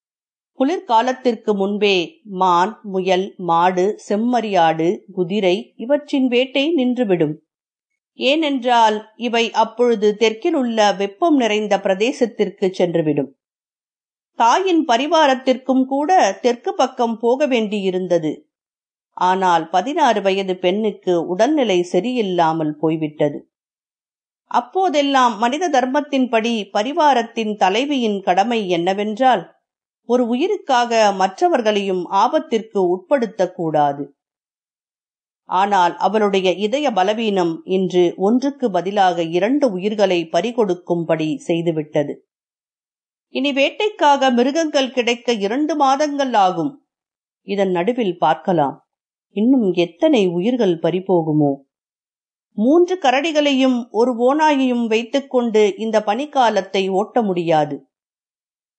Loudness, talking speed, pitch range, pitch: -18 LUFS, 80 wpm, 185-260 Hz, 215 Hz